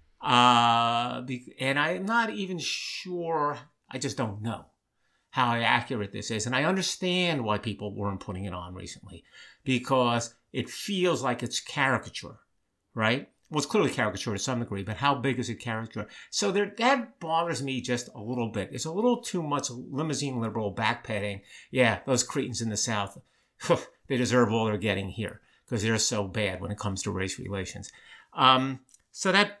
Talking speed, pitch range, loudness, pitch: 170 wpm, 105-145 Hz, -28 LUFS, 120 Hz